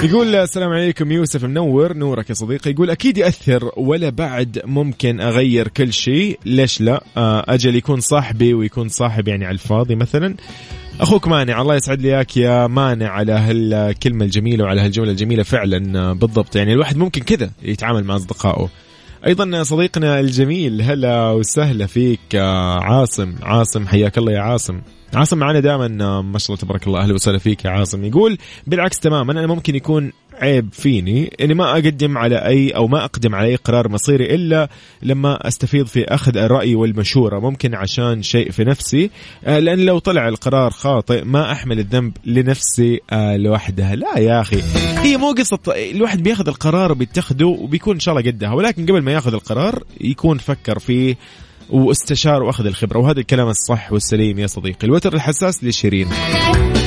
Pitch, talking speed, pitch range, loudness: 125 Hz, 160 wpm, 110-150 Hz, -16 LUFS